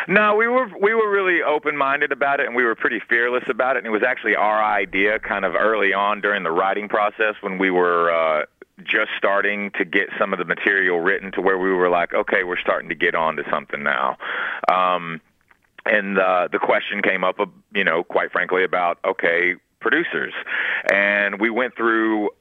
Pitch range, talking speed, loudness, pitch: 95-140 Hz, 200 wpm, -20 LUFS, 105 Hz